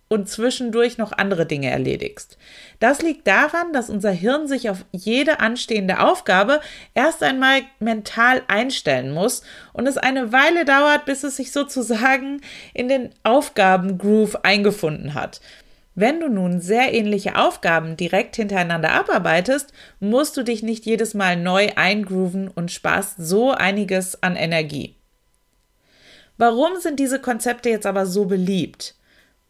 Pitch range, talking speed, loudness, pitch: 190-265 Hz, 135 wpm, -19 LUFS, 225 Hz